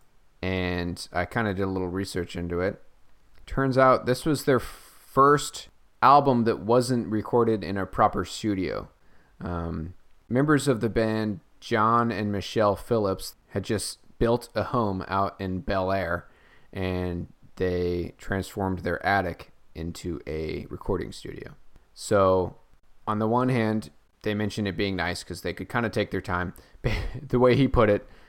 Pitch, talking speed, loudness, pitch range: 100 Hz, 155 wpm, -26 LUFS, 90-115 Hz